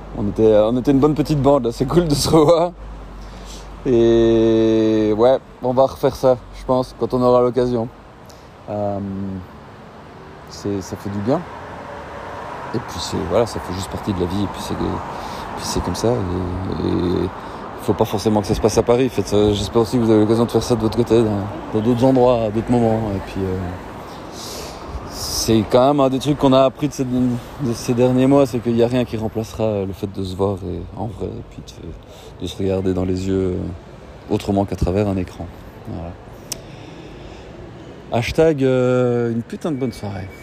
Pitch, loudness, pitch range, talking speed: 110 Hz, -18 LUFS, 100-125 Hz, 210 wpm